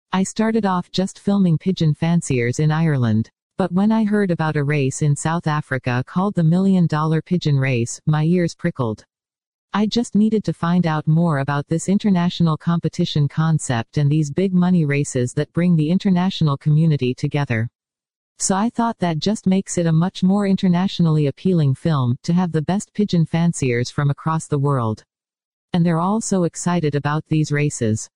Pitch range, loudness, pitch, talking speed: 145-185 Hz, -19 LUFS, 165 Hz, 175 wpm